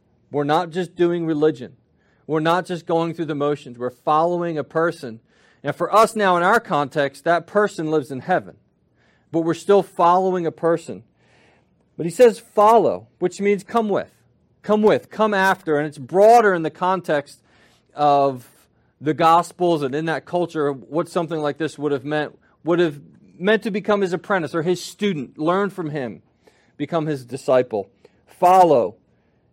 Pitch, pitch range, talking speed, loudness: 165 Hz, 145-185 Hz, 170 wpm, -20 LUFS